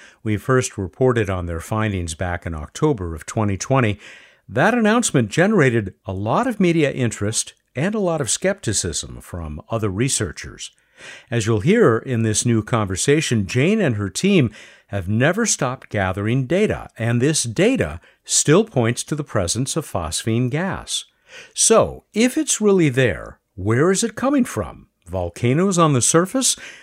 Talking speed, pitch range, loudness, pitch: 150 wpm, 105-170 Hz, -19 LUFS, 120 Hz